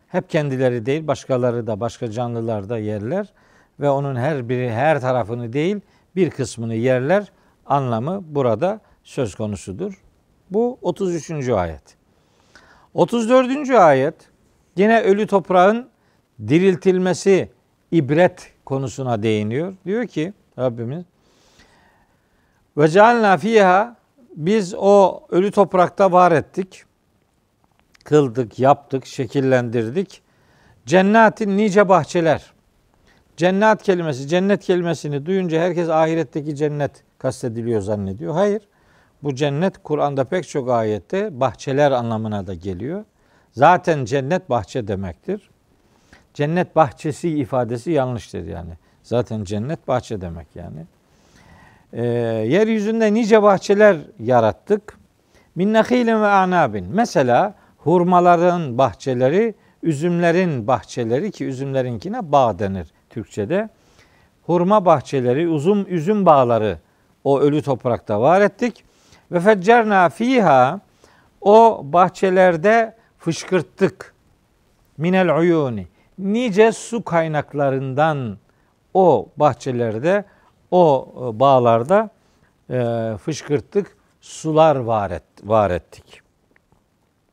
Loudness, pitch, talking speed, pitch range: -18 LUFS, 155 Hz, 90 wpm, 125-190 Hz